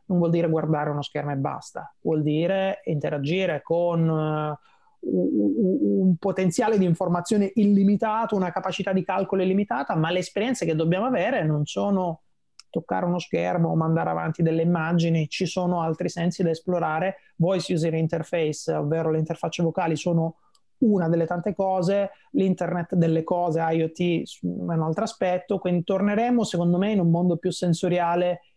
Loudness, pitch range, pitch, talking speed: -24 LUFS, 165-190 Hz, 175 Hz, 160 wpm